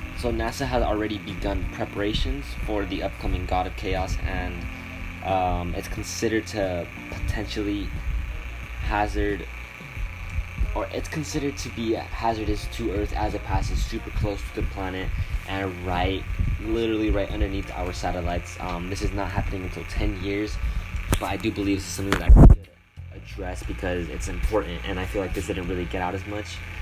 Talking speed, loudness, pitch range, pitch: 170 wpm, -27 LUFS, 90-100 Hz, 95 Hz